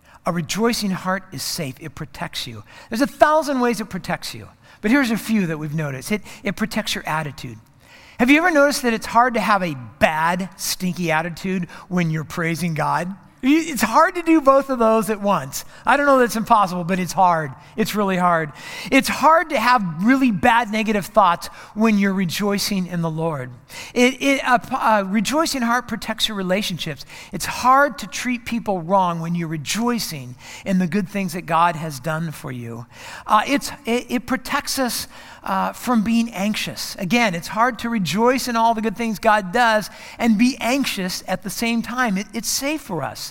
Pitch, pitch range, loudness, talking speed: 205 Hz, 170-235 Hz, -20 LUFS, 195 wpm